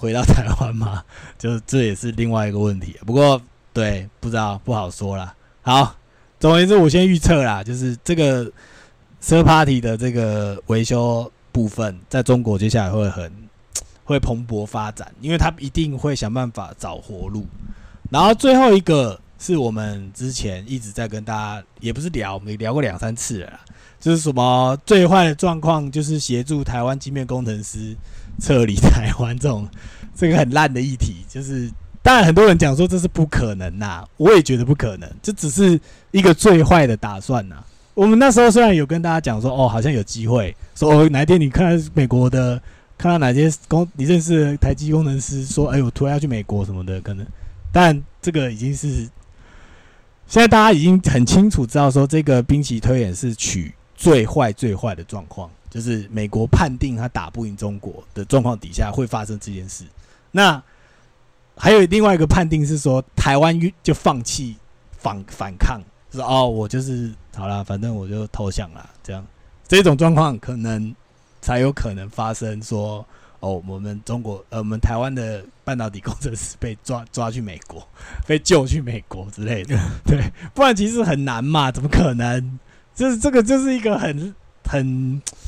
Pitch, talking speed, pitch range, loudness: 120 Hz, 280 characters per minute, 105-150 Hz, -18 LUFS